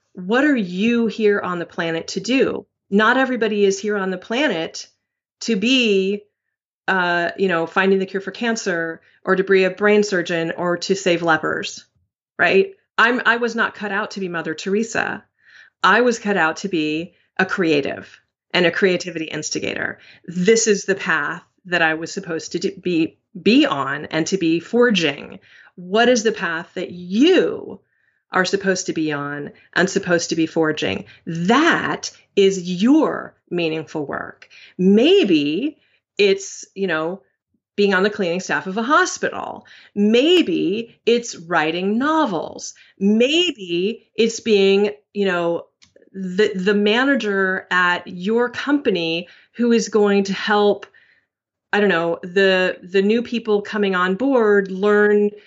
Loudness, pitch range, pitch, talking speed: -19 LUFS, 175-225 Hz, 195 Hz, 150 wpm